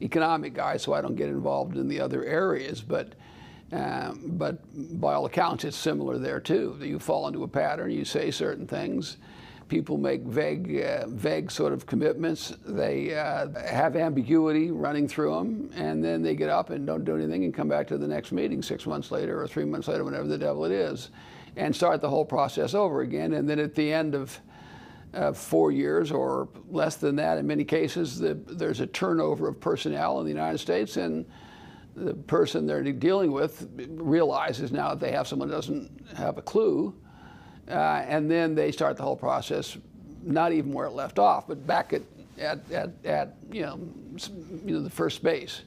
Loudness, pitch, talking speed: -28 LUFS, 145 Hz, 195 wpm